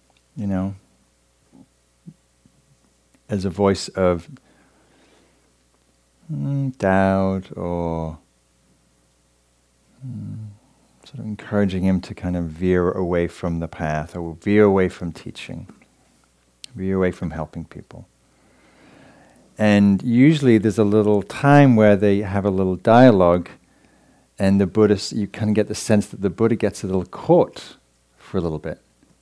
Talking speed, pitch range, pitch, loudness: 130 wpm, 75-105 Hz, 95 Hz, -19 LUFS